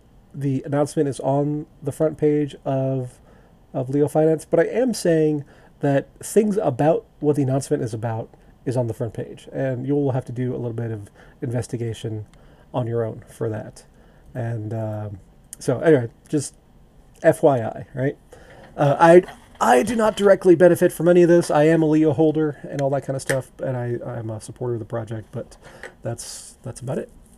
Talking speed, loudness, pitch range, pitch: 190 wpm, -21 LUFS, 120-155 Hz, 140 Hz